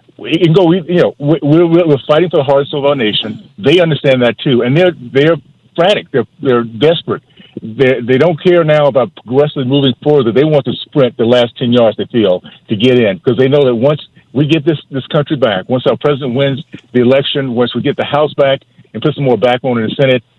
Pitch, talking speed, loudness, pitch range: 140 Hz, 235 wpm, -11 LUFS, 125-150 Hz